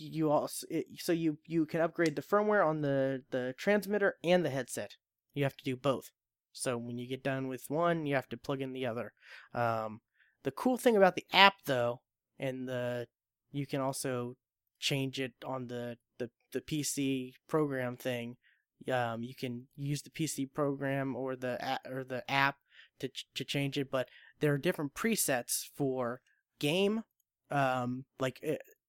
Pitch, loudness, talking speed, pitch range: 135 Hz, -34 LUFS, 180 wpm, 125-150 Hz